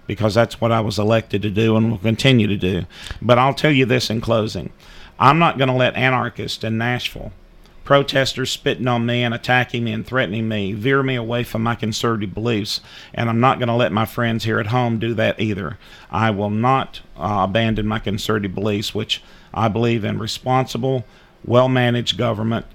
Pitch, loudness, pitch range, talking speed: 115 Hz, -19 LUFS, 110-125 Hz, 200 wpm